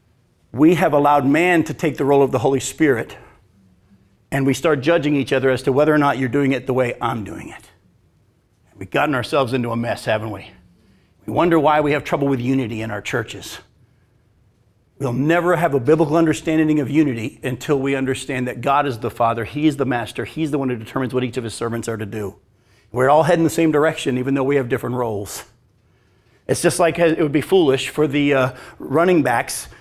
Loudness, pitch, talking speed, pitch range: -18 LUFS, 135 Hz, 215 wpm, 115-150 Hz